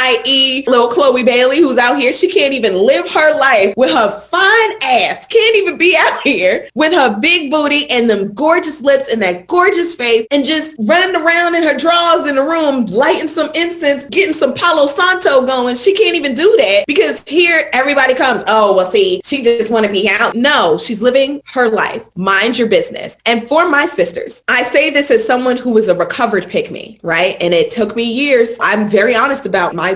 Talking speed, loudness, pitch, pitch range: 210 wpm, -11 LUFS, 280 Hz, 235-335 Hz